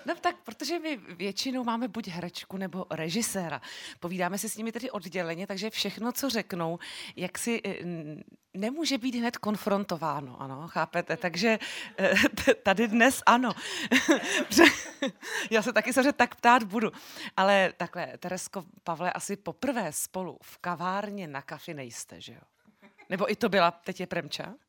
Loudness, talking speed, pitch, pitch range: -28 LUFS, 150 wpm, 200 Hz, 175-235 Hz